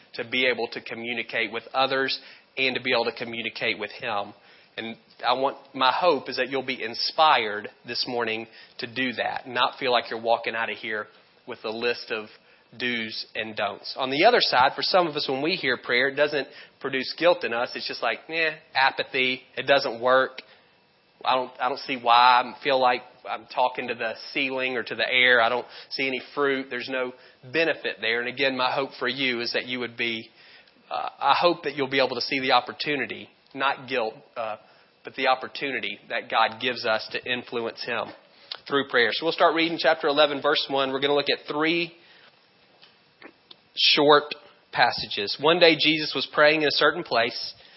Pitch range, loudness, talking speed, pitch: 120-145 Hz, -24 LUFS, 200 wpm, 130 Hz